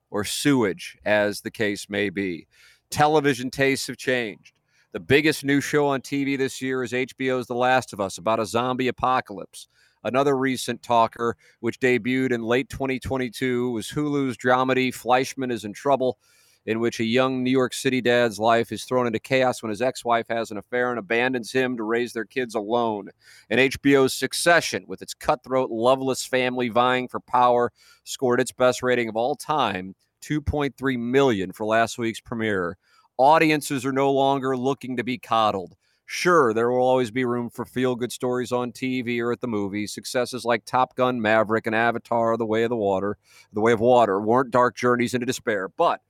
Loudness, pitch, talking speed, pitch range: -23 LUFS, 125 Hz, 180 wpm, 115-130 Hz